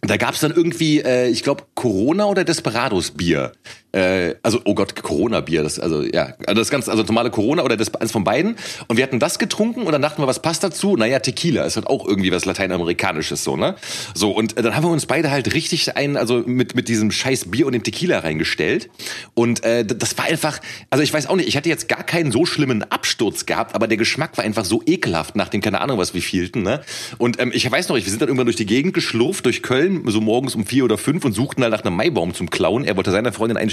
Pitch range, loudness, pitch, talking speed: 110-150 Hz, -19 LUFS, 120 Hz, 255 wpm